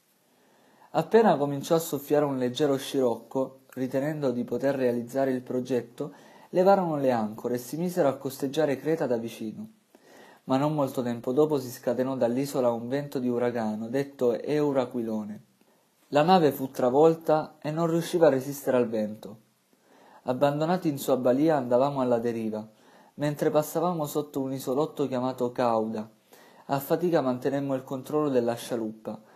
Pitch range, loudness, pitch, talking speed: 120-150 Hz, -27 LUFS, 135 Hz, 145 wpm